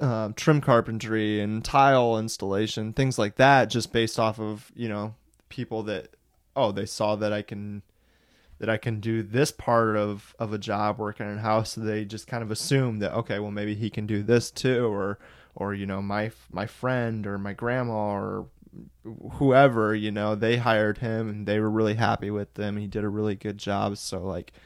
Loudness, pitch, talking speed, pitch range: -26 LUFS, 110 Hz, 205 wpm, 105-115 Hz